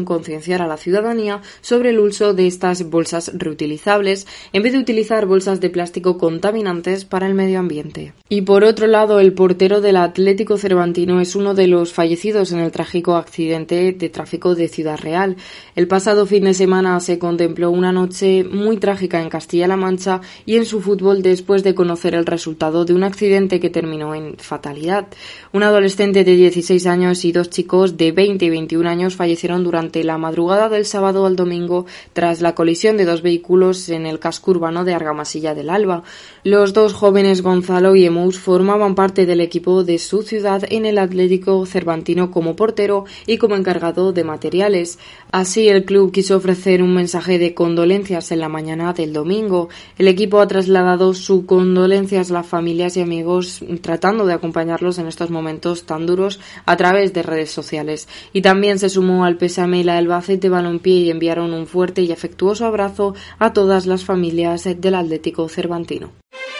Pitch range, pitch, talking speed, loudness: 170-195 Hz, 180 Hz, 180 wpm, -16 LUFS